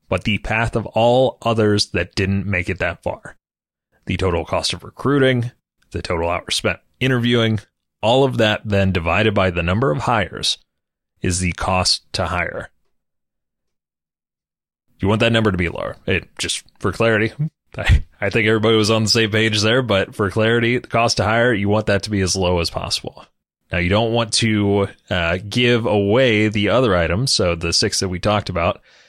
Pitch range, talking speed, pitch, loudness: 95-115 Hz, 190 wpm, 105 Hz, -18 LUFS